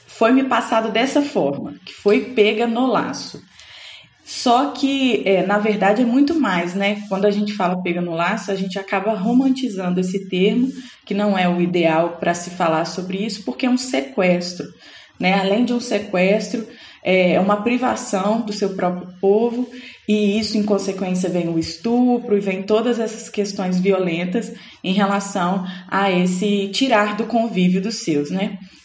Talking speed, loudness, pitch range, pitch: 165 wpm, -19 LUFS, 185-230 Hz, 205 Hz